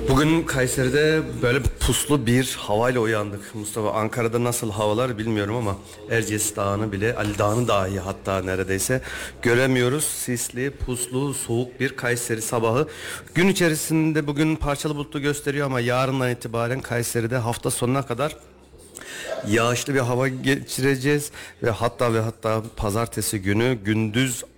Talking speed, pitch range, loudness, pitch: 125 wpm, 110-135 Hz, -23 LUFS, 120 Hz